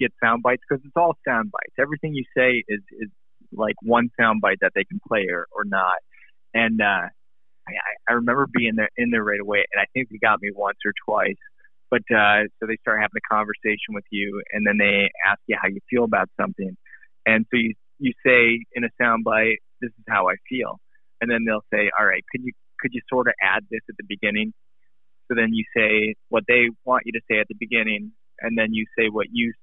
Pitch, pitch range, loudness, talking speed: 110 Hz, 105-120 Hz, -21 LUFS, 230 wpm